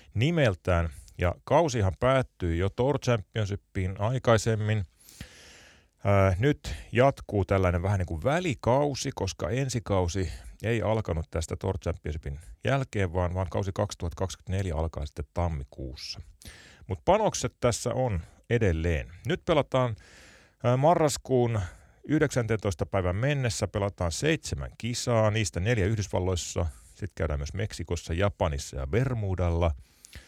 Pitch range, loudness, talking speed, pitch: 85-115 Hz, -28 LUFS, 115 wpm, 100 Hz